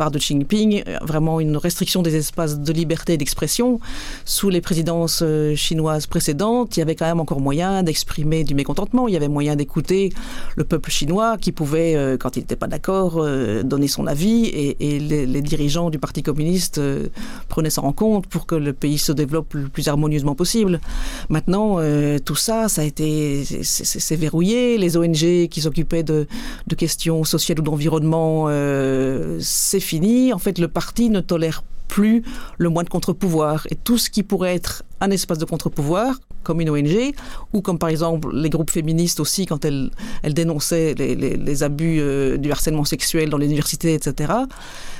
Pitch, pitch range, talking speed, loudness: 160 Hz, 150-180 Hz, 190 wpm, -20 LUFS